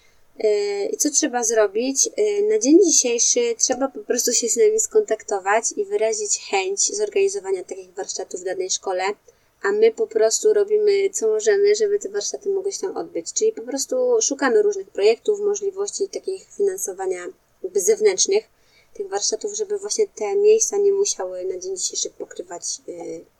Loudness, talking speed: -20 LUFS, 155 wpm